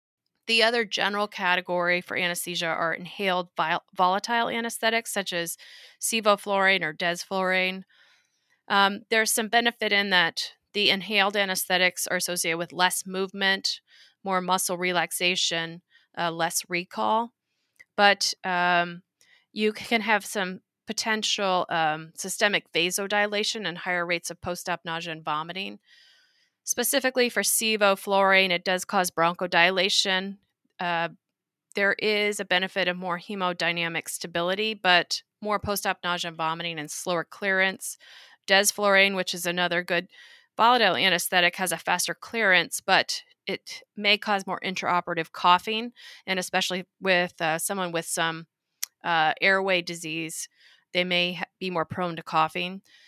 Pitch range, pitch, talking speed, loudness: 175-205 Hz, 185 Hz, 130 wpm, -25 LUFS